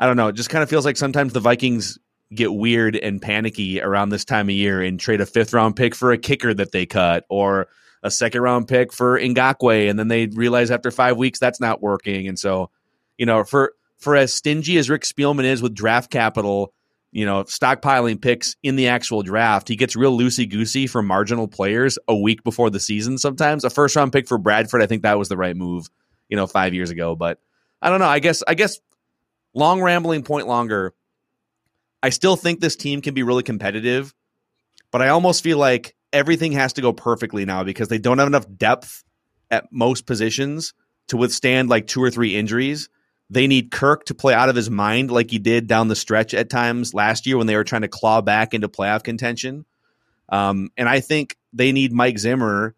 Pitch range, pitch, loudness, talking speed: 105-130 Hz, 120 Hz, -19 LUFS, 215 wpm